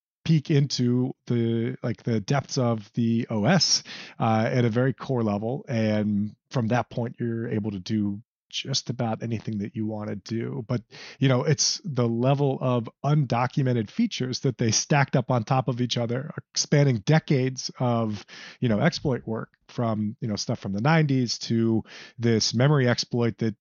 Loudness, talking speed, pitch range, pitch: -25 LUFS, 175 wpm, 115-135 Hz, 120 Hz